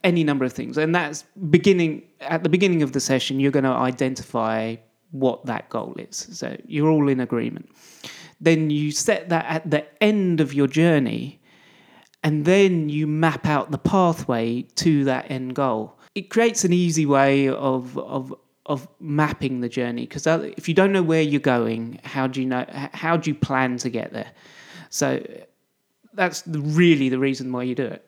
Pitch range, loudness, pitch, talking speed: 130-165 Hz, -22 LUFS, 150 Hz, 185 wpm